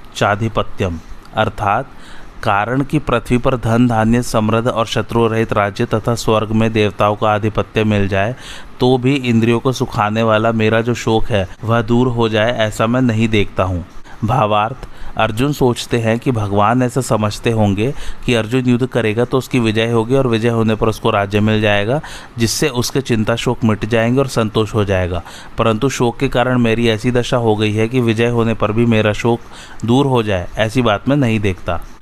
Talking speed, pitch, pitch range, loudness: 185 wpm, 115 Hz, 105-125 Hz, -16 LUFS